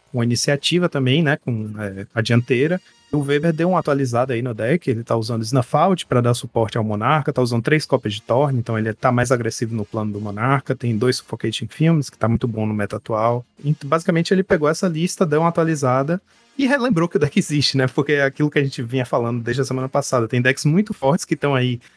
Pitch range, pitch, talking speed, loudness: 115-155 Hz, 130 Hz, 235 wpm, -20 LUFS